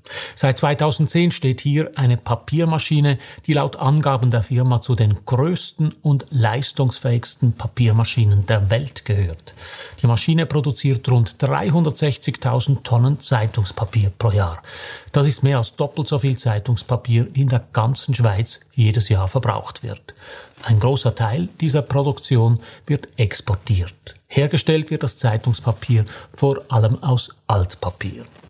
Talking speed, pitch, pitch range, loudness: 130 wpm, 125 Hz, 115-145 Hz, -19 LUFS